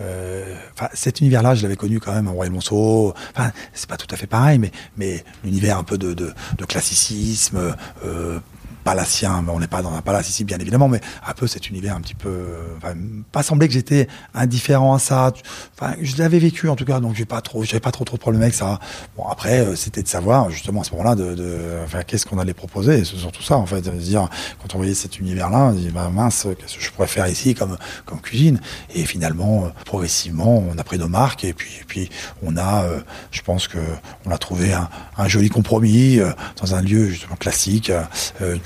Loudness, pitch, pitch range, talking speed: -20 LUFS, 100 Hz, 90-115 Hz, 225 wpm